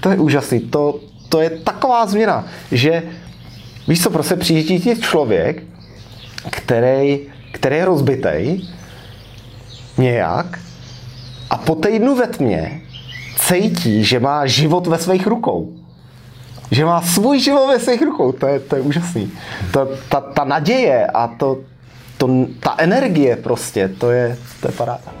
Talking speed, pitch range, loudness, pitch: 145 wpm, 125-175 Hz, -16 LUFS, 140 Hz